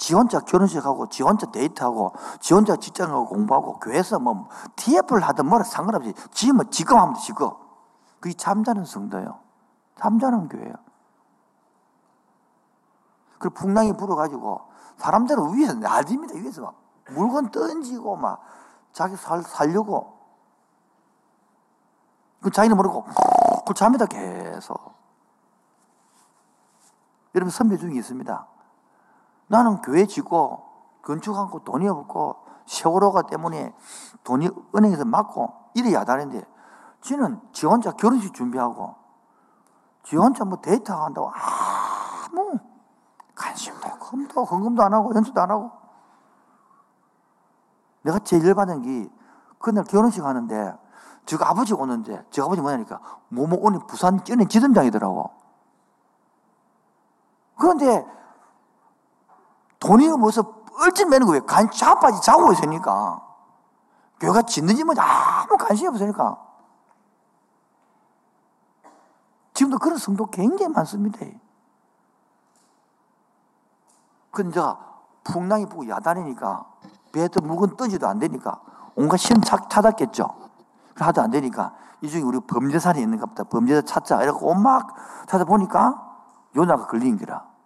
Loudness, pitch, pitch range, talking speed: -21 LUFS, 215 Hz, 185-245 Hz, 260 characters per minute